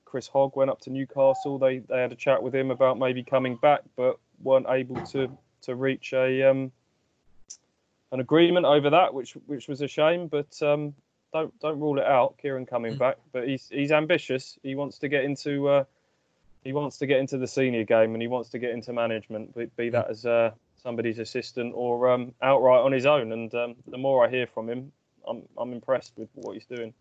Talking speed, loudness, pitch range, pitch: 215 wpm, -26 LUFS, 120-140 Hz, 130 Hz